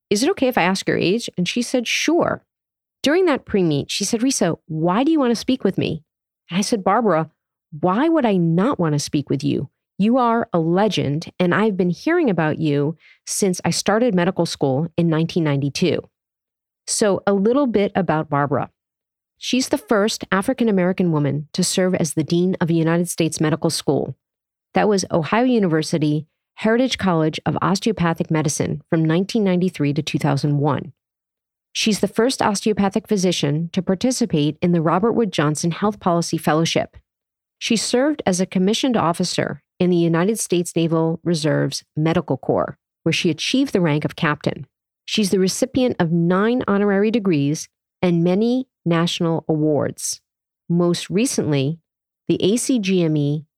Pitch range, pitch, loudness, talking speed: 160-215 Hz, 180 Hz, -19 LUFS, 160 wpm